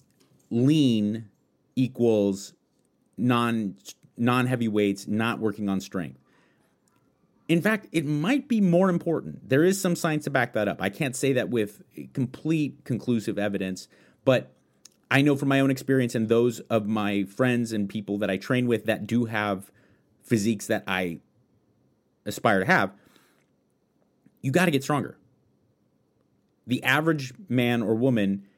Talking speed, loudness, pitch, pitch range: 145 wpm, -25 LUFS, 120 Hz, 105-135 Hz